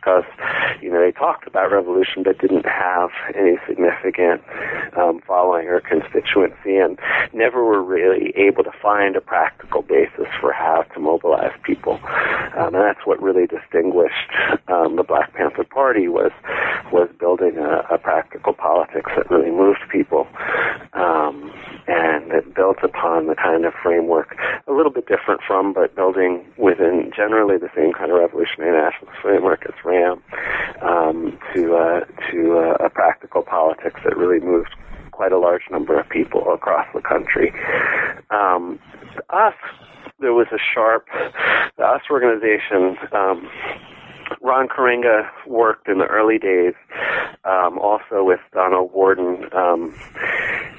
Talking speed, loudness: 145 wpm, -18 LUFS